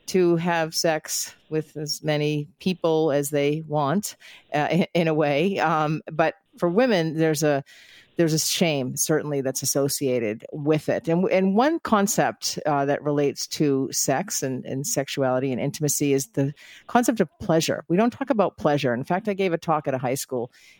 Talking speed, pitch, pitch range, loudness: 180 wpm, 155 Hz, 140-175 Hz, -23 LUFS